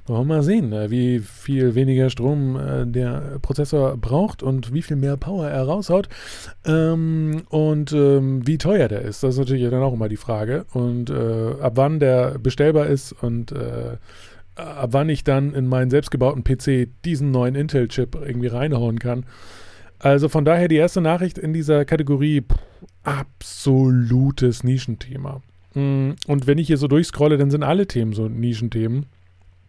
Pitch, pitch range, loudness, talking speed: 135 Hz, 120-150 Hz, -20 LUFS, 150 wpm